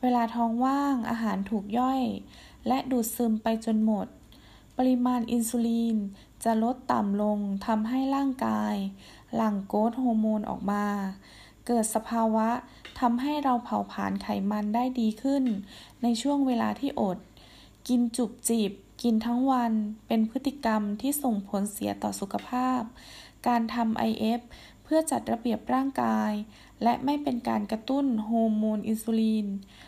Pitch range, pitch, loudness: 215-250 Hz, 230 Hz, -28 LUFS